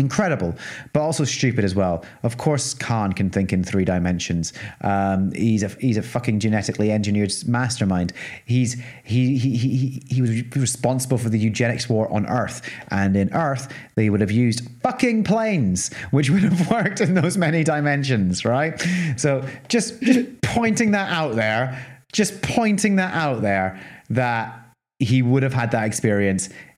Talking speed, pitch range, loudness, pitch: 160 wpm, 110-150 Hz, -21 LUFS, 125 Hz